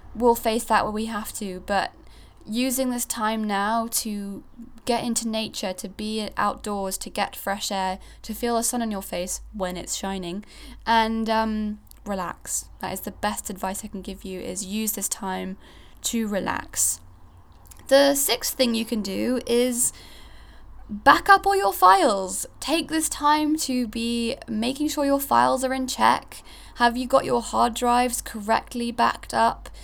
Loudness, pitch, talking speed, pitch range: -24 LUFS, 220 Hz, 170 wpm, 195-240 Hz